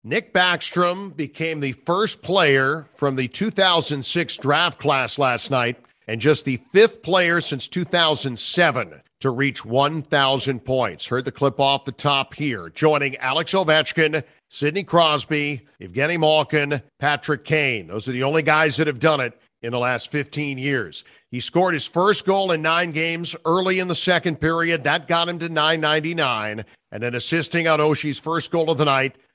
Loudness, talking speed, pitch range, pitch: -20 LUFS, 170 wpm, 135-165 Hz, 150 Hz